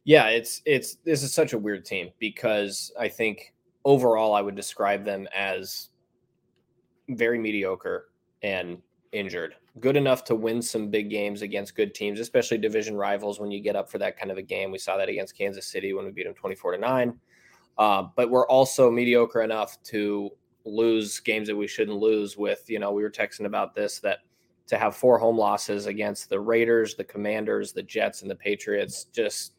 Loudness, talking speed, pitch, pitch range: -26 LUFS, 195 wpm, 110 Hz, 105-120 Hz